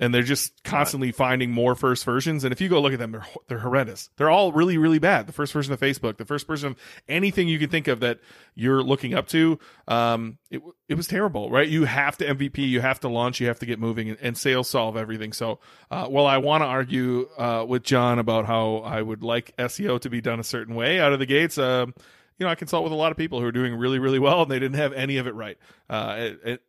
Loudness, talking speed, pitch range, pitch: -23 LUFS, 270 wpm, 120-145 Hz, 130 Hz